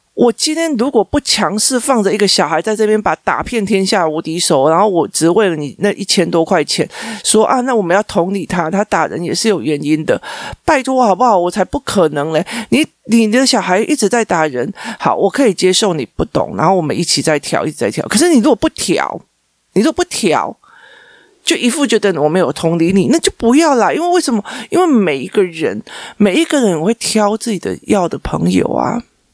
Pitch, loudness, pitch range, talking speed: 210 Hz, -13 LUFS, 180-250 Hz, 310 characters per minute